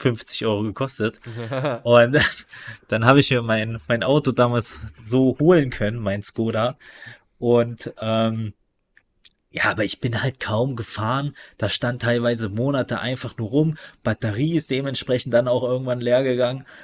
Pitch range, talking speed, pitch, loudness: 115-130 Hz, 145 wpm, 120 Hz, -21 LUFS